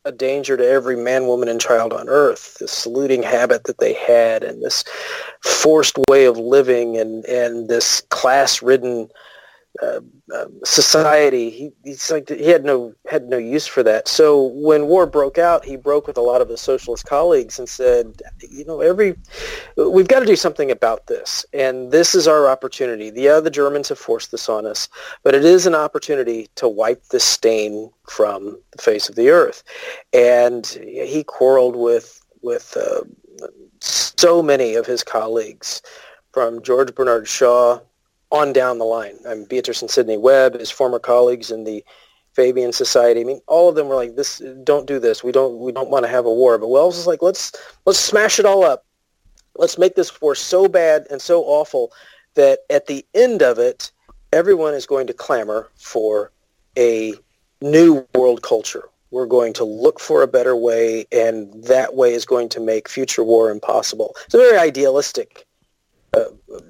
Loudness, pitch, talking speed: -16 LUFS, 145 Hz, 185 wpm